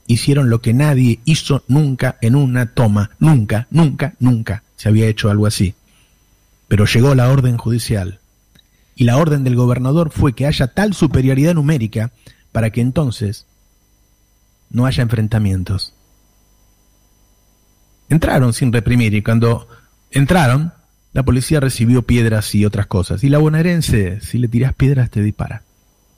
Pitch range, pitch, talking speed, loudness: 105-135 Hz, 120 Hz, 140 wpm, -15 LUFS